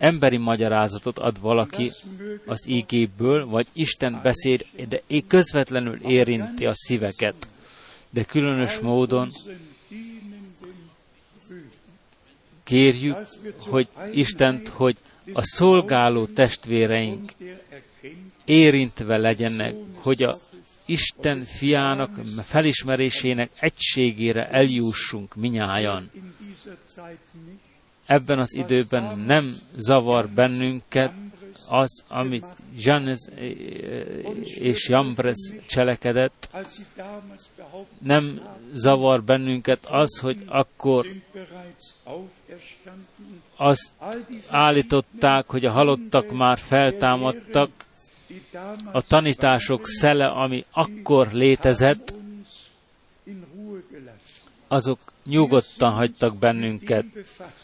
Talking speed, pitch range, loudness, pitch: 70 wpm, 125-170 Hz, -21 LUFS, 135 Hz